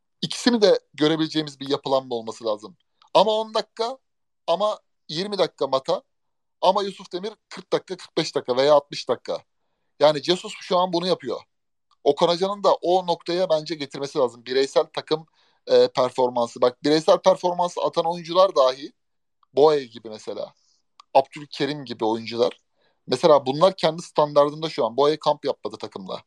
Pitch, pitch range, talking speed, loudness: 160 Hz, 140-185 Hz, 145 wpm, -22 LUFS